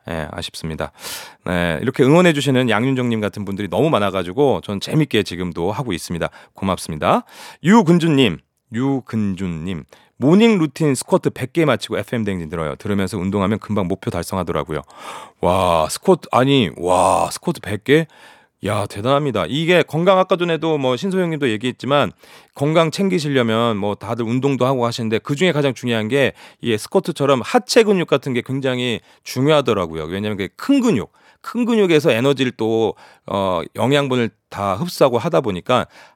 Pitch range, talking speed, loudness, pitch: 100-155 Hz, 365 characters per minute, -18 LUFS, 125 Hz